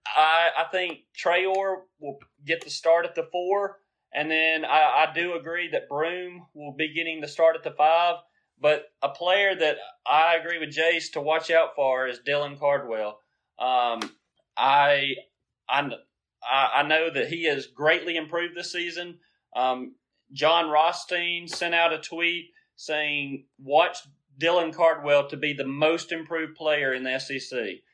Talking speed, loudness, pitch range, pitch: 160 wpm, -24 LUFS, 145-175 Hz, 160 Hz